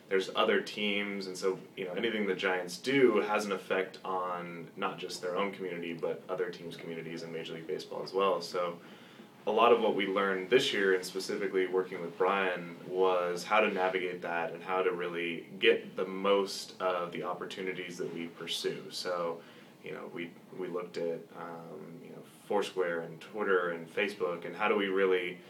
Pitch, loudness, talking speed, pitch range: 90 Hz, -32 LUFS, 195 wpm, 85-95 Hz